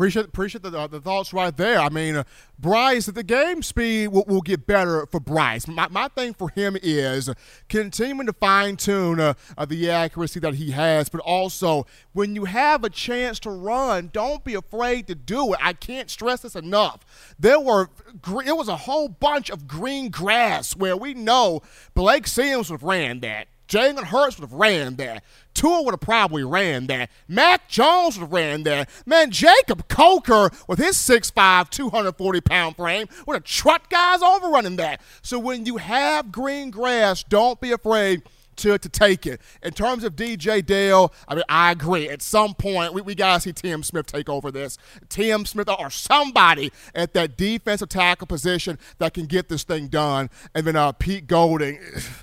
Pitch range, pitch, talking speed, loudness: 165-235 Hz, 195 Hz, 190 wpm, -20 LUFS